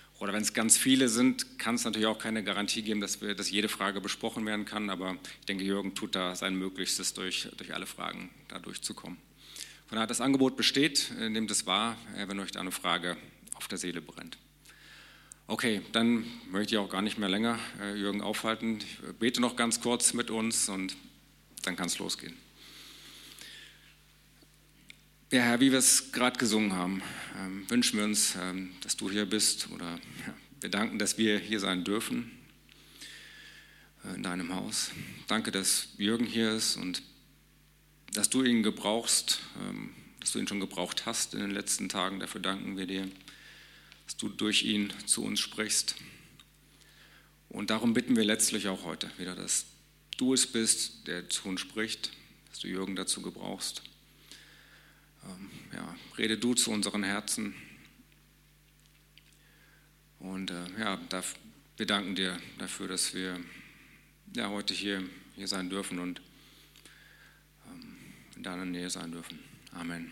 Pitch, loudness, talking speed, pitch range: 105 Hz, -31 LUFS, 155 wpm, 95-115 Hz